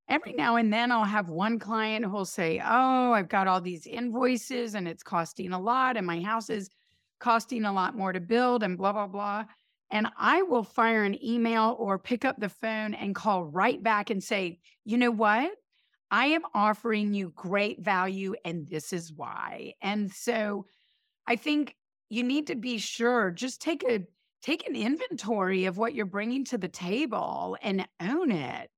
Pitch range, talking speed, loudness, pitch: 195-240 Hz, 190 wpm, -29 LUFS, 215 Hz